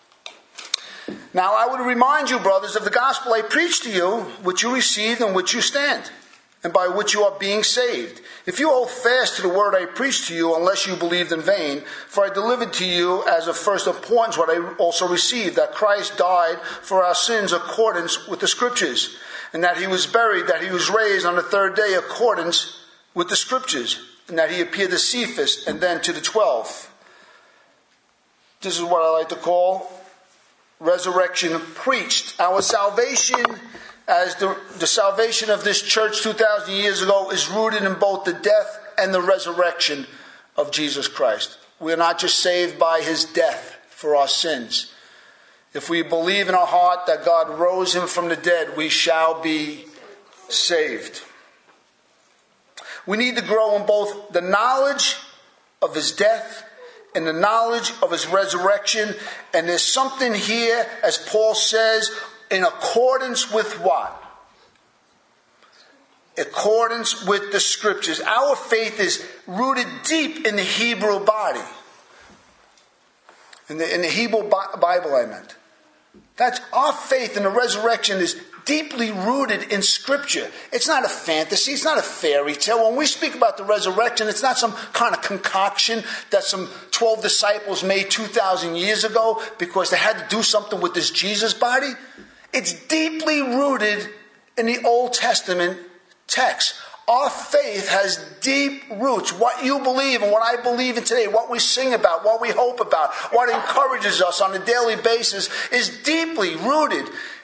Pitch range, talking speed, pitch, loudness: 180-240 Hz, 165 wpm, 210 Hz, -20 LUFS